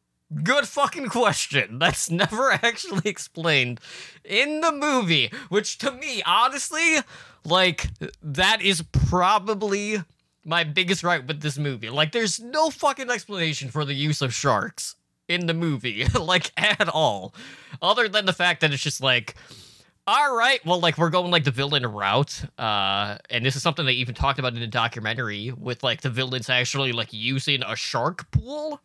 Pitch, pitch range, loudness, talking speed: 160 Hz, 130-210 Hz, -23 LUFS, 165 wpm